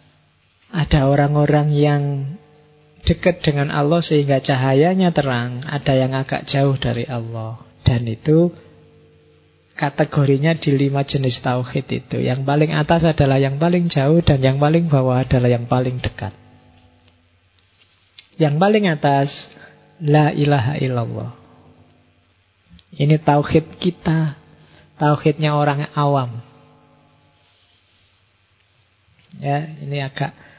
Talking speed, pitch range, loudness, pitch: 105 wpm, 115-150 Hz, -18 LUFS, 140 Hz